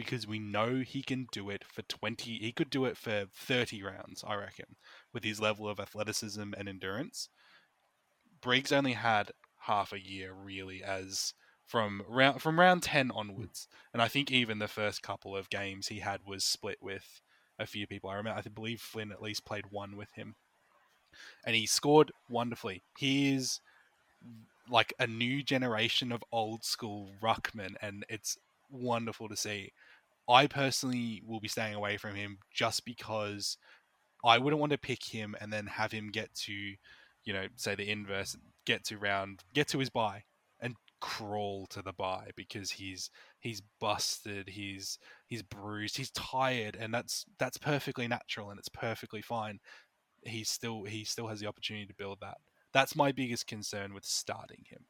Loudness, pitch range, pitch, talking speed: -34 LUFS, 100-120 Hz, 110 Hz, 175 wpm